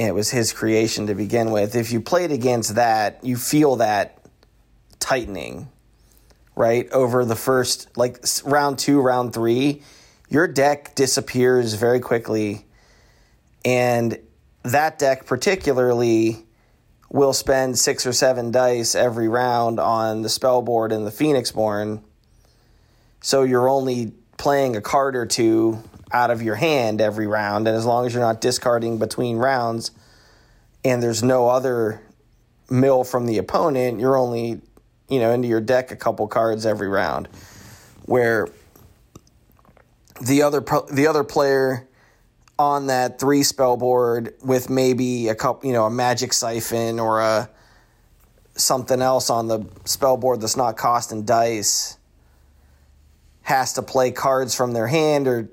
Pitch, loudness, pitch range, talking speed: 120 Hz, -20 LUFS, 110-130 Hz, 145 wpm